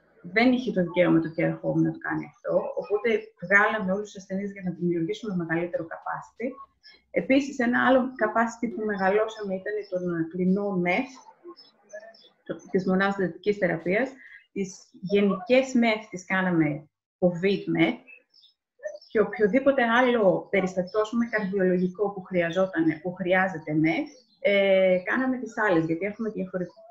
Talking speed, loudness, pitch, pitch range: 140 wpm, -25 LUFS, 195 Hz, 180-230 Hz